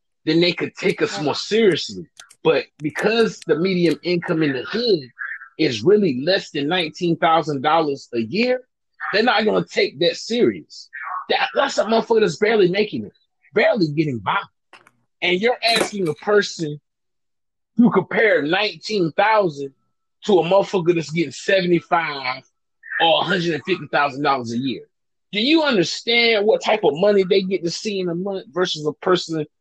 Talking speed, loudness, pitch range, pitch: 150 wpm, -19 LUFS, 160-210 Hz, 180 Hz